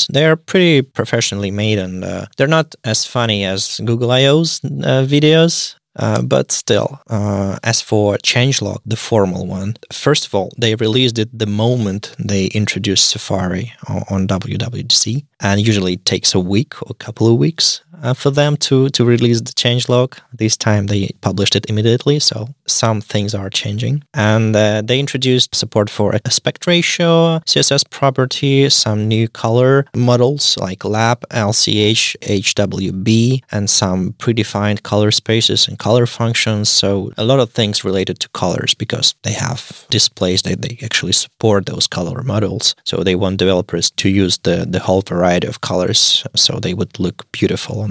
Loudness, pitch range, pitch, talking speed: -15 LUFS, 100-130 Hz, 110 Hz, 170 wpm